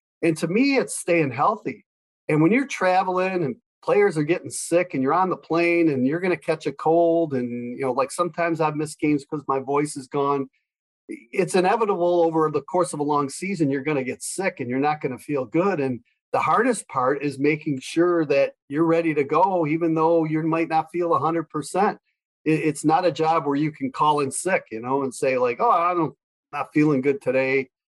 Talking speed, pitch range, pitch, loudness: 215 wpm, 145-175 Hz, 160 Hz, -22 LUFS